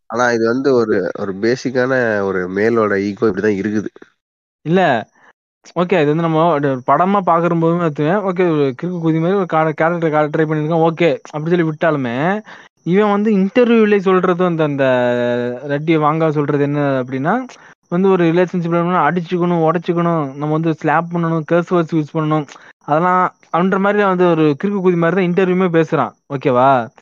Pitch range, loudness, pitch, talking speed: 145-180 Hz, -16 LUFS, 165 Hz, 150 wpm